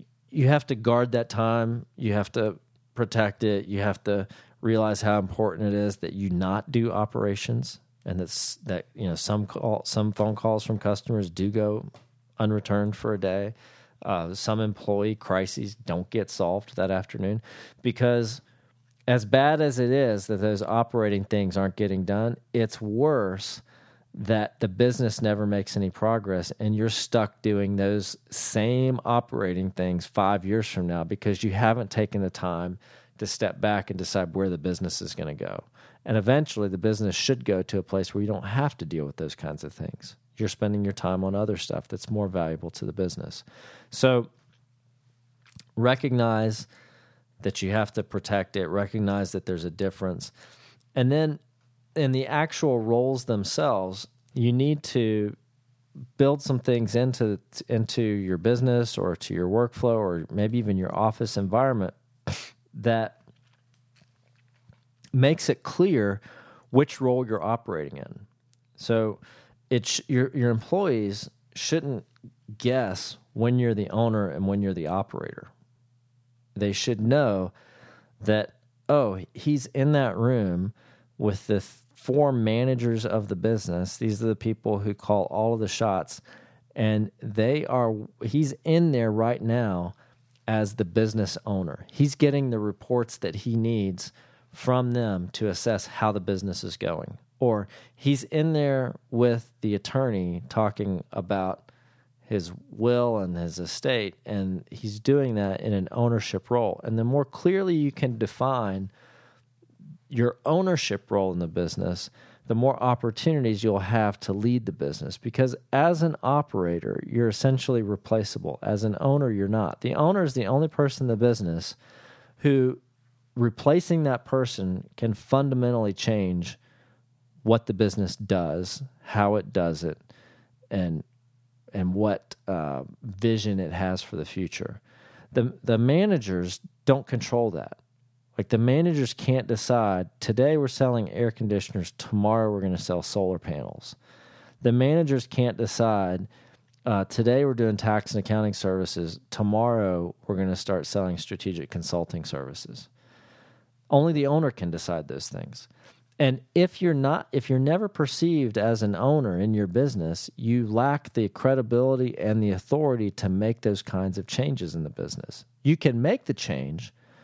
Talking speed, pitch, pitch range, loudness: 155 wpm, 115 Hz, 100-125 Hz, -26 LUFS